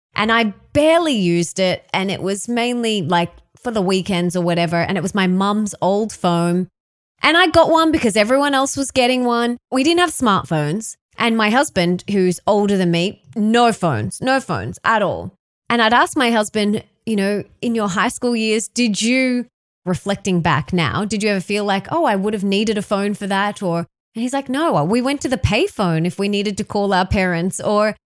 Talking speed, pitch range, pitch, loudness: 210 wpm, 185-240 Hz, 210 Hz, -18 LUFS